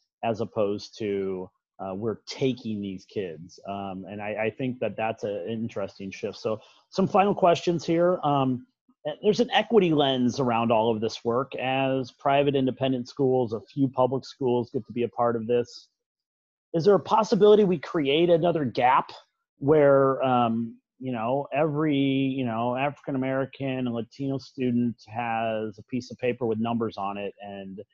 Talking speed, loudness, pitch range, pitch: 170 wpm, -26 LUFS, 115-145 Hz, 130 Hz